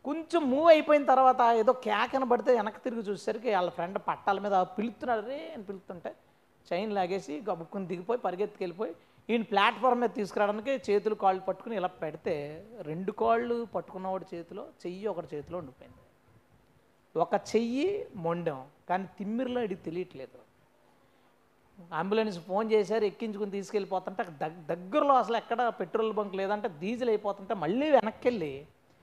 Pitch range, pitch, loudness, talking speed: 185-235 Hz, 210 Hz, -30 LUFS, 130 wpm